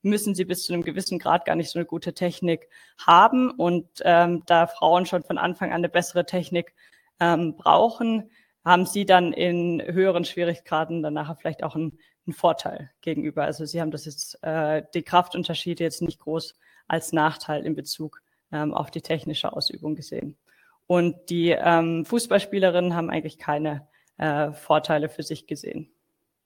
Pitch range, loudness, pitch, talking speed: 155-175 Hz, -24 LUFS, 170 Hz, 165 wpm